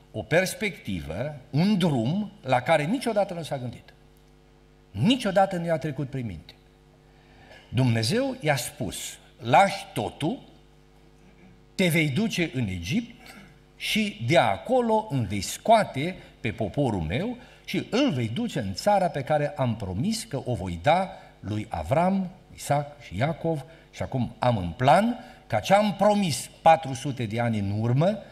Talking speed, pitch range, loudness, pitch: 145 wpm, 120-195 Hz, -26 LUFS, 150 Hz